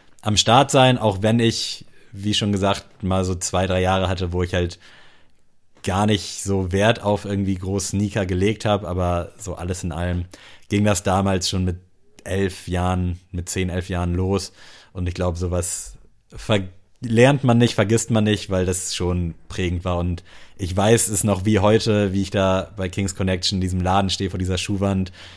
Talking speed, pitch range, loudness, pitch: 190 wpm, 90-105 Hz, -21 LUFS, 95 Hz